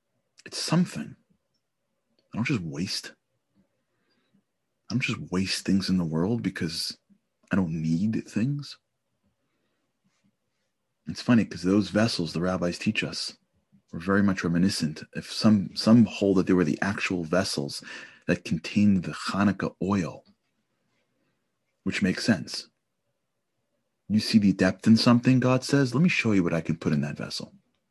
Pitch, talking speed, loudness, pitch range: 95 Hz, 150 wpm, -26 LUFS, 90-115 Hz